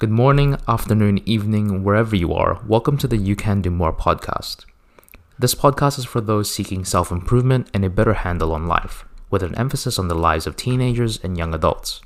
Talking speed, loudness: 200 wpm, -19 LUFS